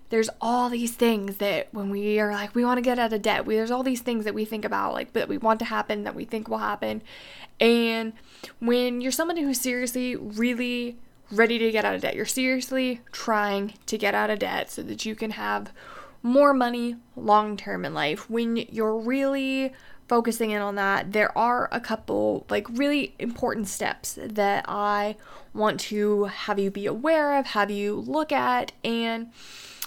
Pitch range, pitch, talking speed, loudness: 210-245 Hz, 230 Hz, 195 wpm, -25 LUFS